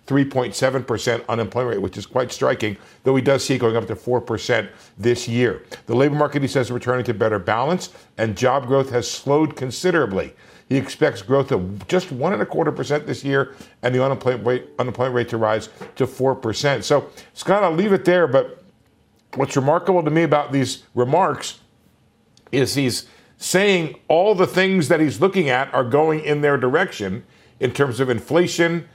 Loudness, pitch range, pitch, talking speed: -20 LUFS, 120-150 Hz, 135 Hz, 190 wpm